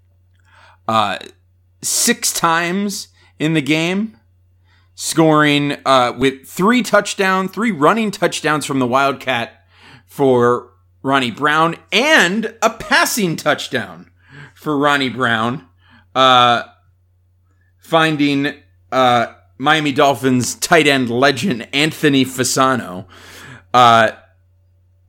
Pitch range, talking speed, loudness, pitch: 95-155 Hz, 90 wpm, -15 LUFS, 130 Hz